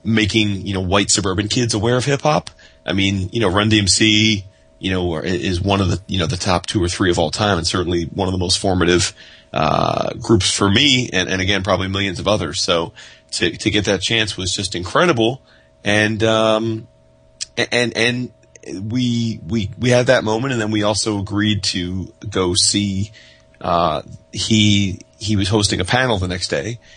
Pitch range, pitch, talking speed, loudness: 90-110 Hz, 100 Hz, 195 wpm, -17 LUFS